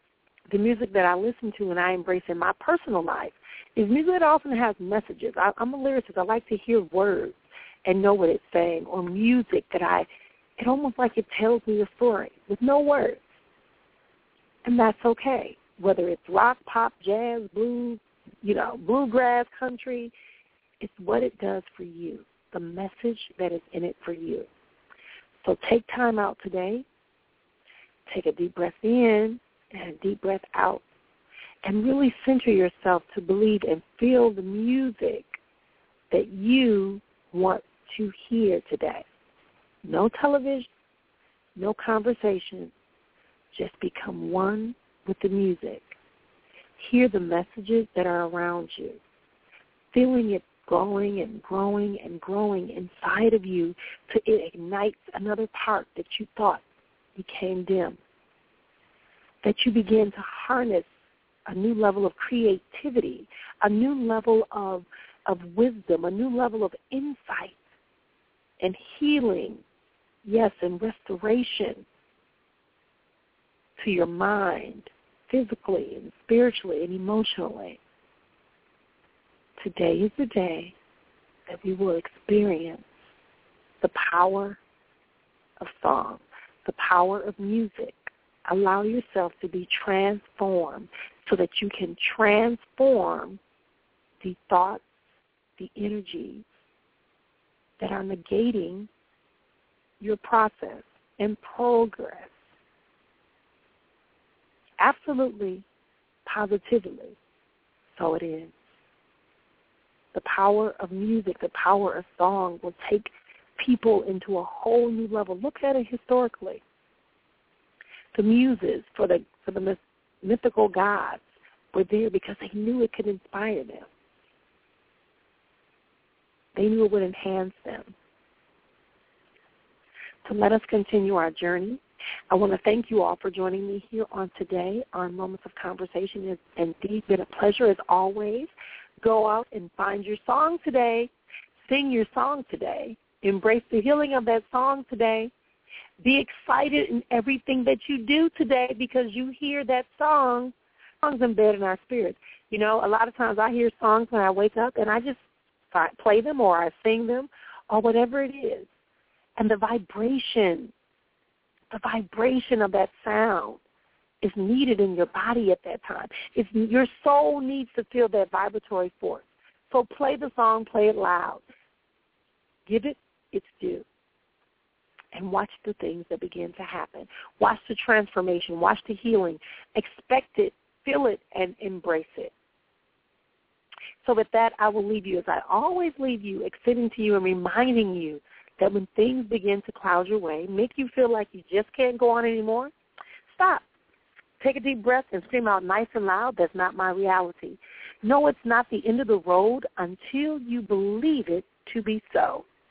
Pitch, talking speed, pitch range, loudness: 215 Hz, 140 wpm, 190-245 Hz, -25 LUFS